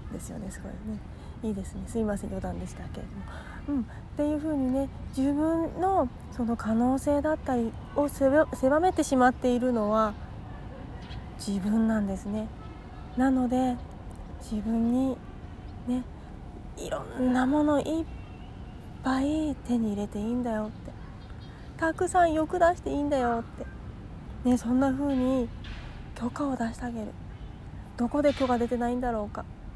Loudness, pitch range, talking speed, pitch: -28 LUFS, 220-285 Hz, 290 characters per minute, 250 Hz